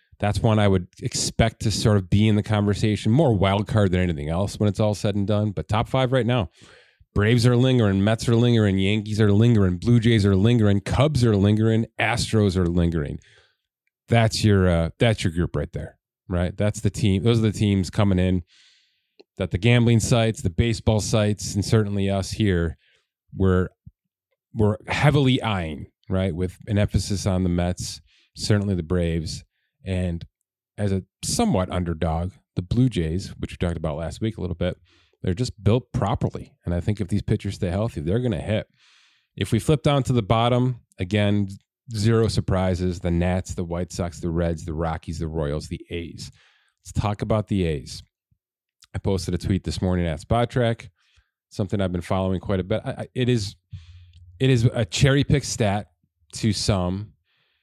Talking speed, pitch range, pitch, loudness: 185 wpm, 90-115 Hz, 100 Hz, -23 LUFS